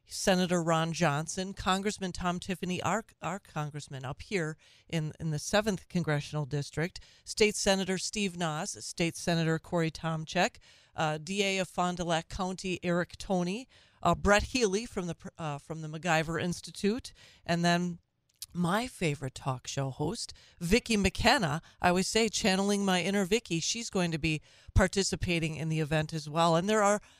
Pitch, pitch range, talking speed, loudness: 175 Hz, 160-195 Hz, 160 wpm, -31 LUFS